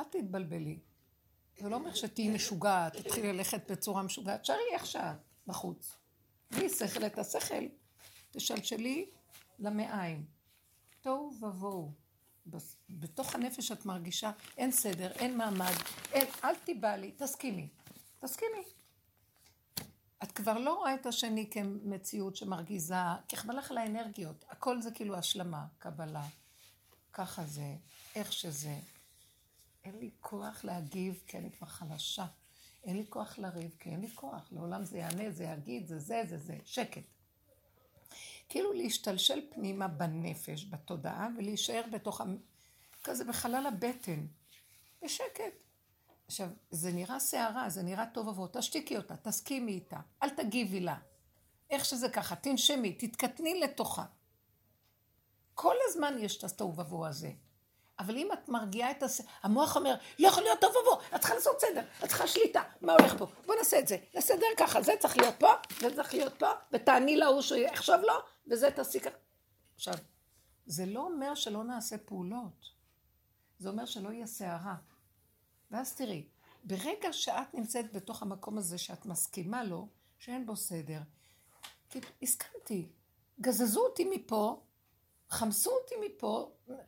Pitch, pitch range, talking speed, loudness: 210 Hz, 175-255 Hz, 140 wpm, -34 LUFS